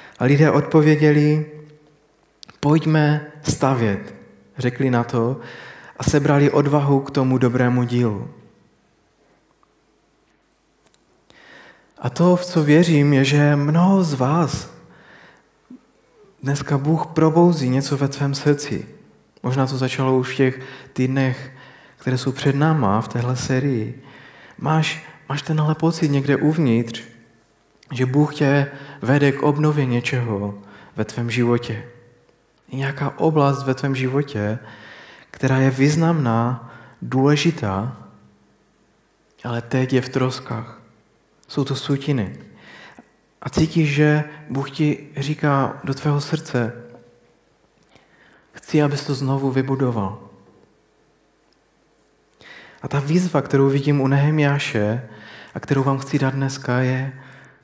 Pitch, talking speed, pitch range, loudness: 135 Hz, 110 wpm, 125-150 Hz, -20 LUFS